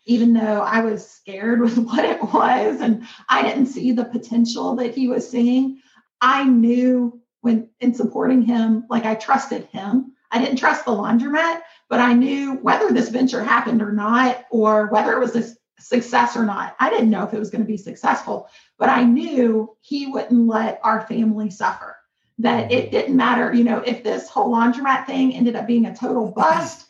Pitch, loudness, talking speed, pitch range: 240 Hz, -19 LUFS, 195 wpm, 225-255 Hz